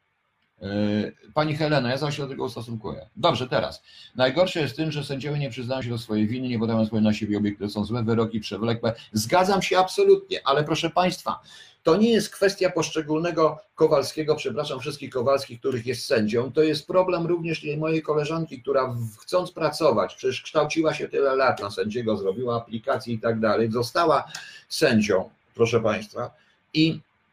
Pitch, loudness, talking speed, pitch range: 140 Hz, -24 LUFS, 165 wpm, 115-160 Hz